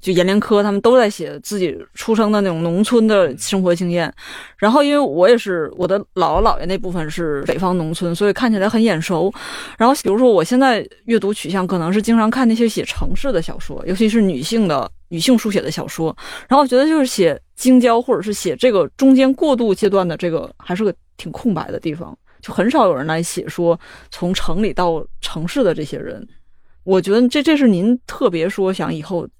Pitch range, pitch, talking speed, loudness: 180-235 Hz, 200 Hz, 320 characters per minute, -17 LUFS